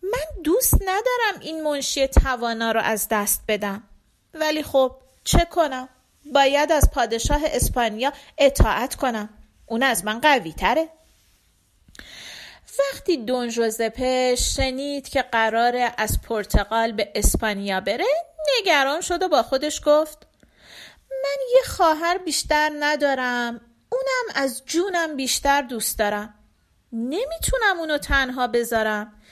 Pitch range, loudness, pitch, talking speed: 235-320 Hz, -22 LUFS, 275 Hz, 115 wpm